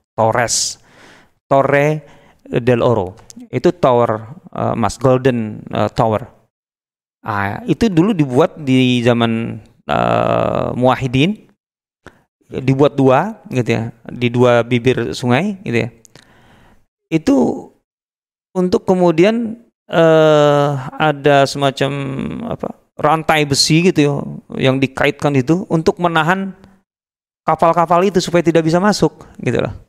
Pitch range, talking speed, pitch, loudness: 120-165 Hz, 105 wpm, 140 Hz, -15 LUFS